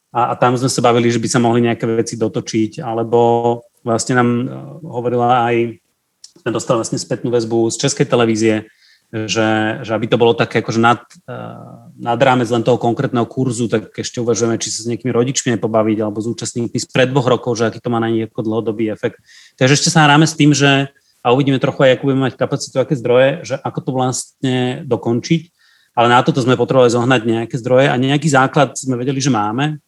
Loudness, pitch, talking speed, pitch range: -15 LUFS, 120 Hz, 200 wpm, 115-135 Hz